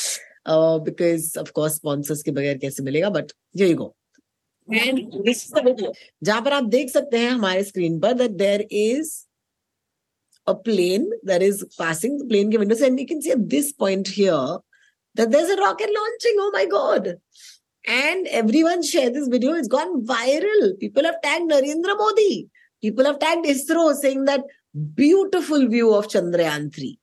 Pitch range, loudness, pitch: 195-300 Hz, -20 LUFS, 250 Hz